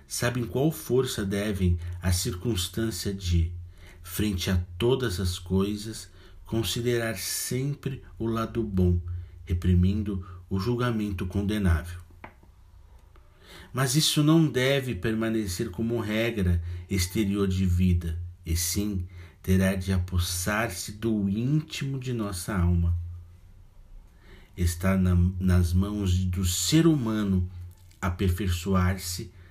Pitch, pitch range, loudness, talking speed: 95 Hz, 90-115 Hz, -27 LUFS, 100 wpm